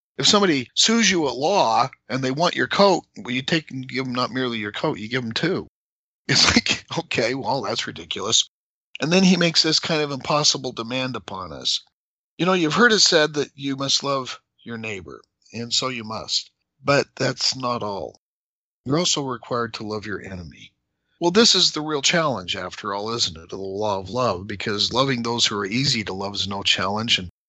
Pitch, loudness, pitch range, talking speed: 130 Hz, -21 LUFS, 105-155 Hz, 205 wpm